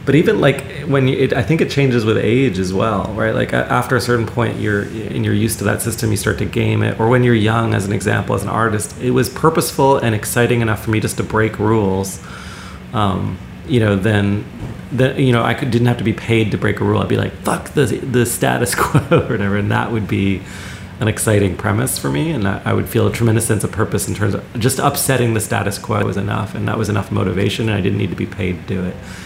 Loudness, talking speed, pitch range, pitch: -17 LUFS, 255 wpm, 100-120 Hz, 110 Hz